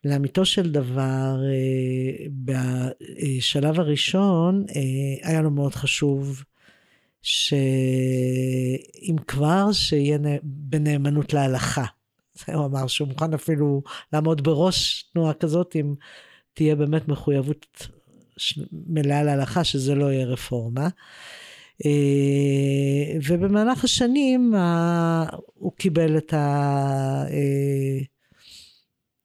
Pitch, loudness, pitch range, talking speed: 145 Hz, -23 LUFS, 135-160 Hz, 80 wpm